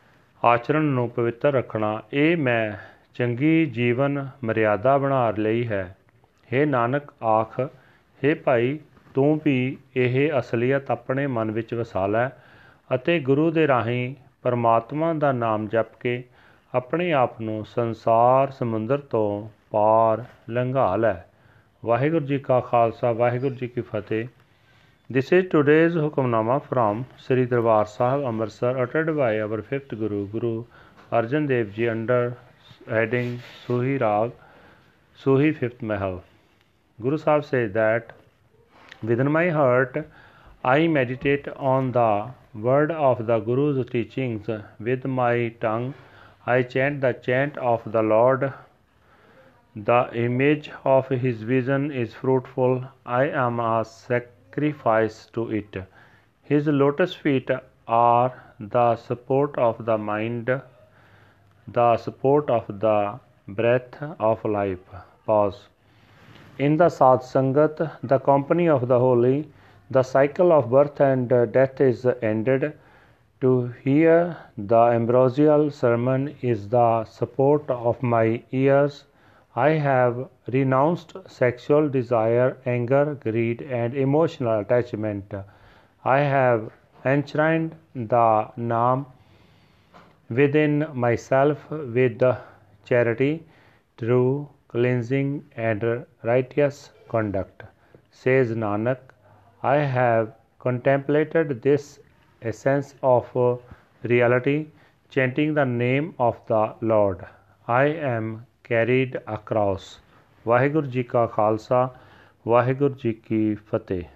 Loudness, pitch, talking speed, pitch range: -23 LUFS, 125 Hz, 110 wpm, 115-140 Hz